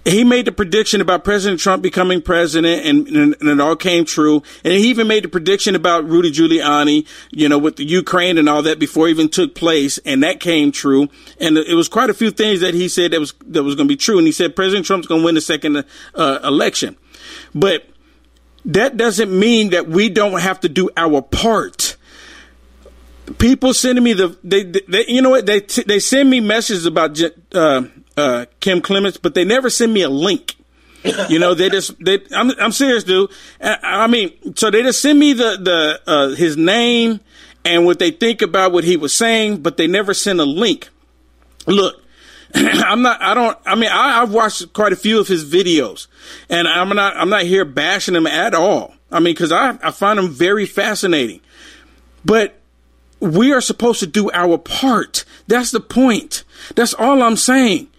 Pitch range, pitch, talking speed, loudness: 170-230 Hz, 190 Hz, 205 wpm, -14 LUFS